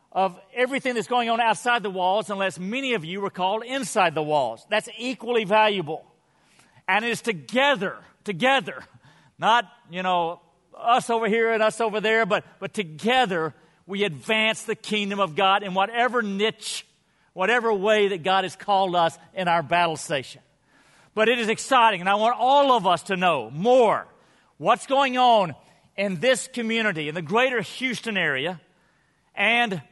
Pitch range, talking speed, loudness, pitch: 180-235 Hz, 165 wpm, -23 LUFS, 210 Hz